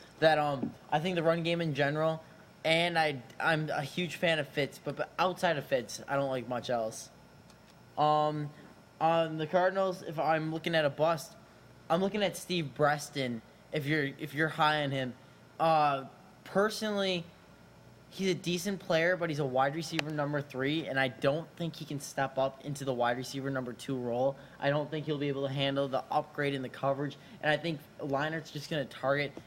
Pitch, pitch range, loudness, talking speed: 150 Hz, 140-165 Hz, -32 LUFS, 200 wpm